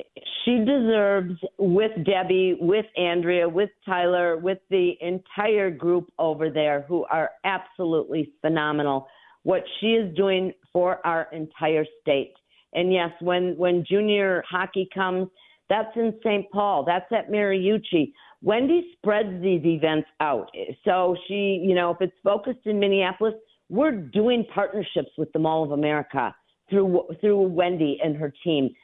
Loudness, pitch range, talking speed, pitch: -24 LUFS, 170-205 Hz, 140 wpm, 185 Hz